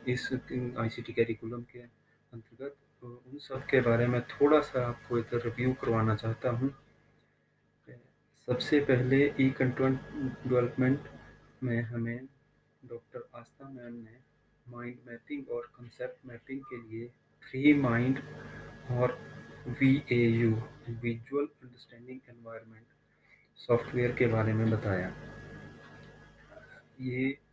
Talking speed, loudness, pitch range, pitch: 120 wpm, -31 LUFS, 115-130 Hz, 120 Hz